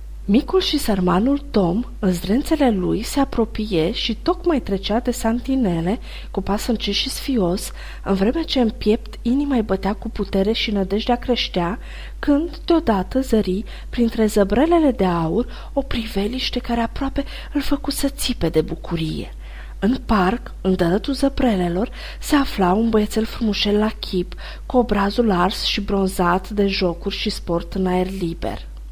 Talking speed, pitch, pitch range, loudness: 150 wpm, 215 Hz, 190-250 Hz, -20 LUFS